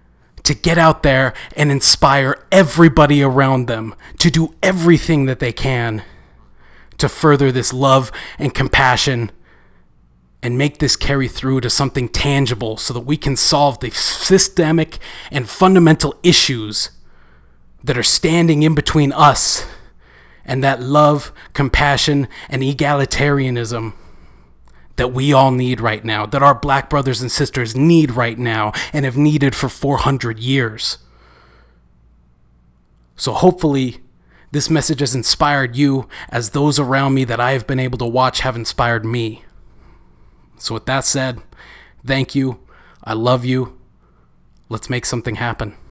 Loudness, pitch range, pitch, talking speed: -15 LUFS, 110-145 Hz, 130 Hz, 140 wpm